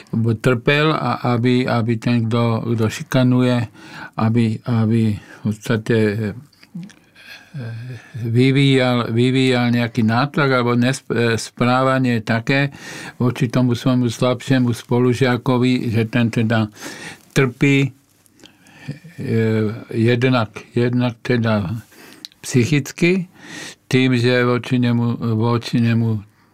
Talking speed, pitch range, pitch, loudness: 85 wpm, 115-130 Hz, 125 Hz, -18 LUFS